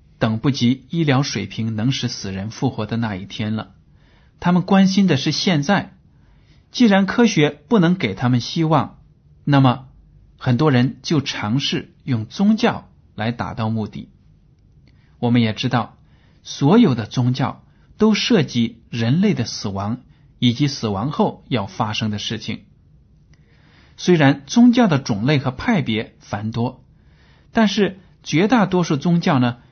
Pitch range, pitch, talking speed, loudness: 115-165 Hz, 130 Hz, 210 characters per minute, -19 LUFS